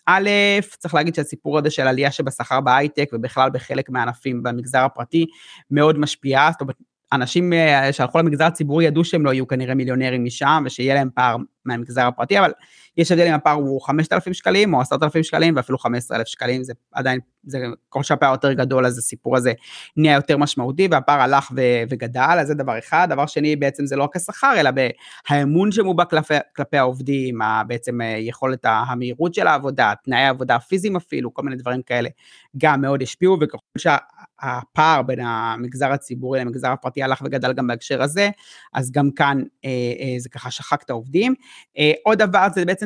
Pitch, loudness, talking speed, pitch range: 135 Hz, -19 LUFS, 175 wpm, 125-155 Hz